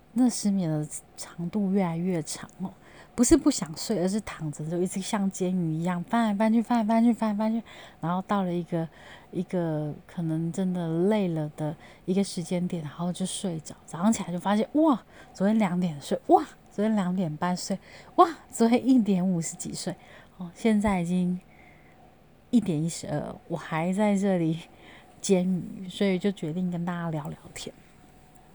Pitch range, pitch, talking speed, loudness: 170-215 Hz, 185 Hz, 260 characters per minute, -27 LUFS